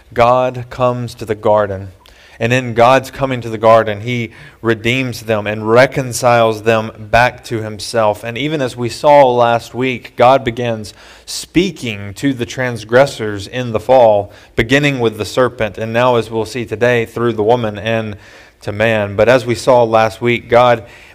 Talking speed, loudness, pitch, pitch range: 170 wpm, -14 LUFS, 115 Hz, 110-125 Hz